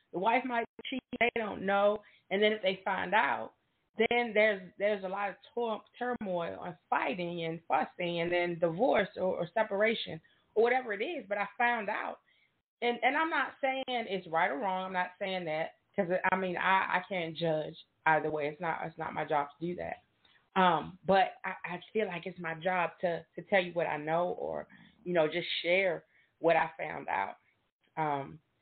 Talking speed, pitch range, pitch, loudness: 200 wpm, 170-215 Hz, 185 Hz, -32 LUFS